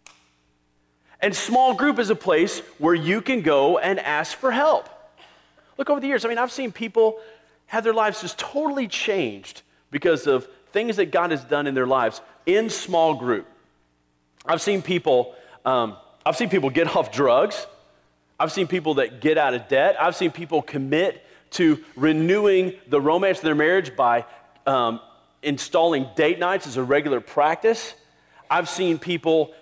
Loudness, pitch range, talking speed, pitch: -22 LUFS, 145-225 Hz, 170 wpm, 175 Hz